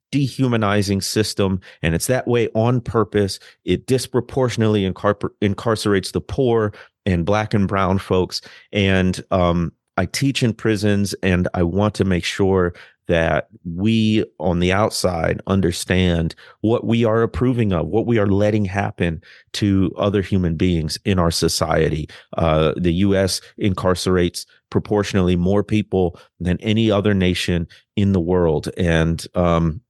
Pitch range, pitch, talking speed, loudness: 90-110 Hz, 95 Hz, 140 wpm, -19 LUFS